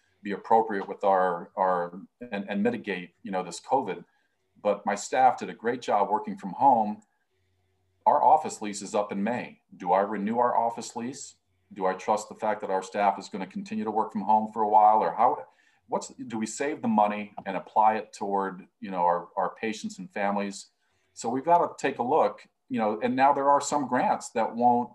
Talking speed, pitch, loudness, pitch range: 215 wpm, 105 Hz, -27 LUFS, 95-115 Hz